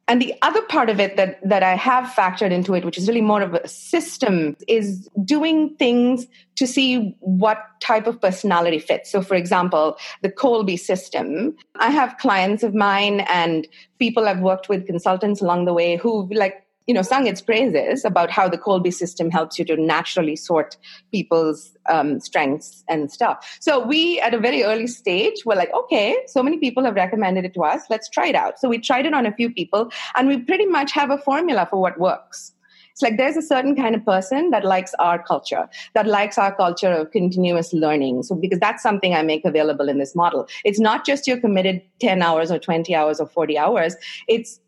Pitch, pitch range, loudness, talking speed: 200 Hz, 175-245 Hz, -19 LUFS, 210 wpm